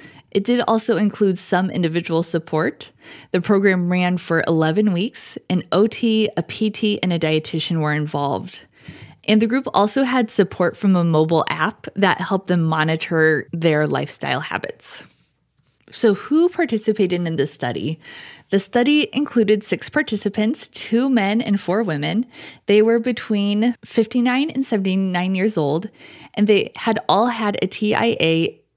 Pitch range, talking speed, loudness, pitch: 170-225 Hz, 145 wpm, -19 LUFS, 200 Hz